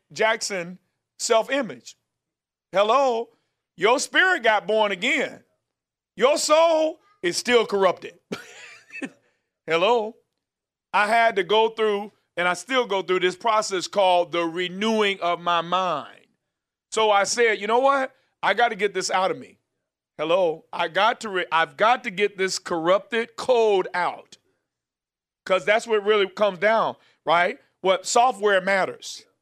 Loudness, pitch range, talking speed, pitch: -22 LUFS, 185-240 Hz, 145 wpm, 215 Hz